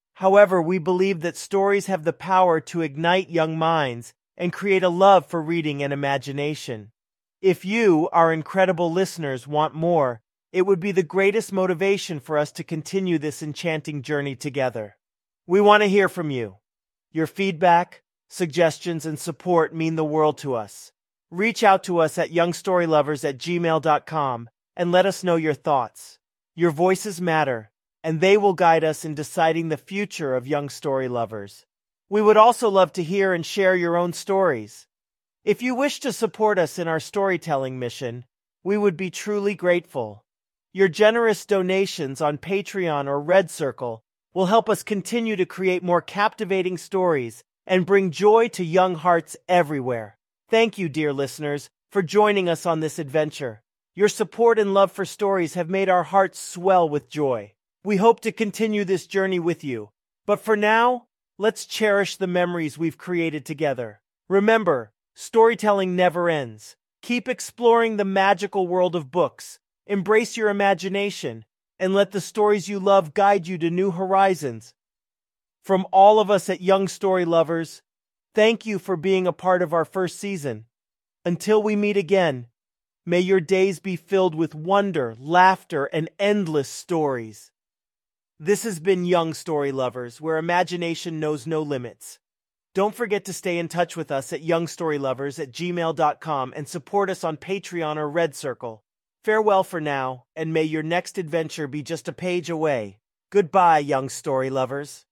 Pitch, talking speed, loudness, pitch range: 175 Hz, 160 wpm, -22 LUFS, 155-195 Hz